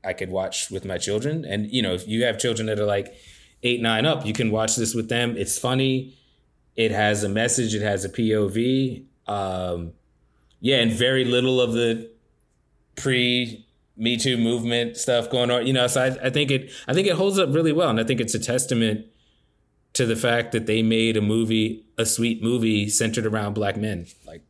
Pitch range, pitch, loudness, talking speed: 110-125 Hz, 115 Hz, -22 LUFS, 210 wpm